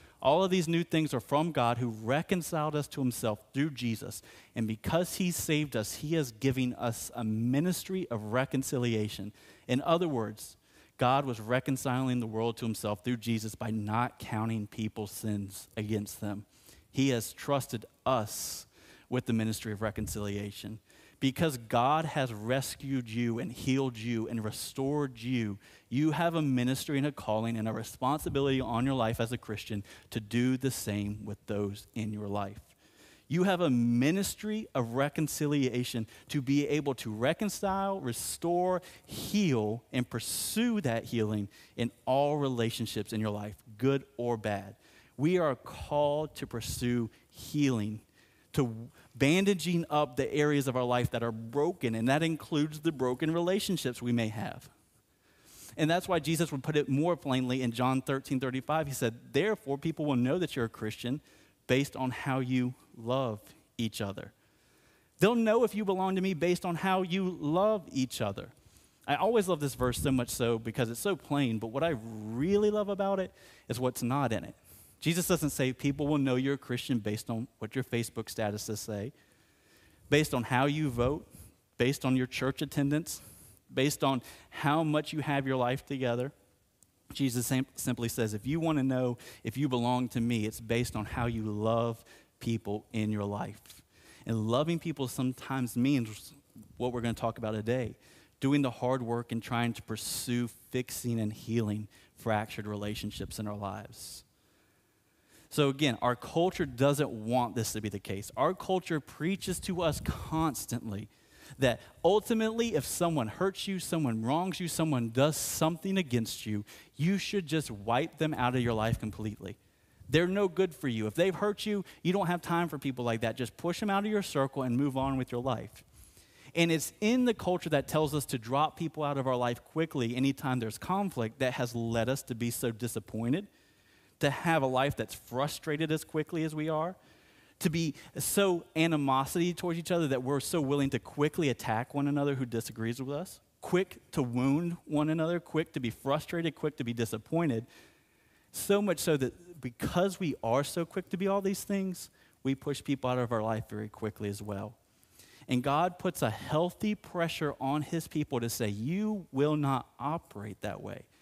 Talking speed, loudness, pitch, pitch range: 180 wpm, -32 LUFS, 130 Hz, 115-155 Hz